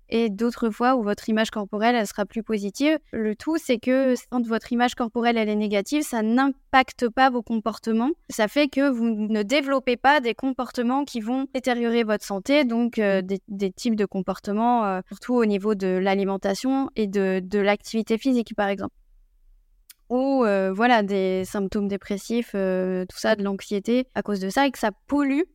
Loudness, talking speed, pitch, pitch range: -23 LUFS, 190 wpm, 230 Hz, 205-255 Hz